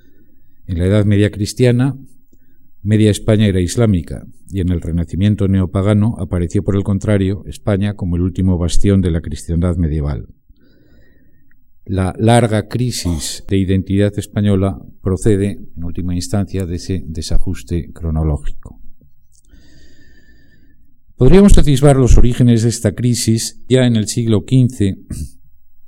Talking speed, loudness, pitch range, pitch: 125 wpm, -15 LUFS, 85-110 Hz, 95 Hz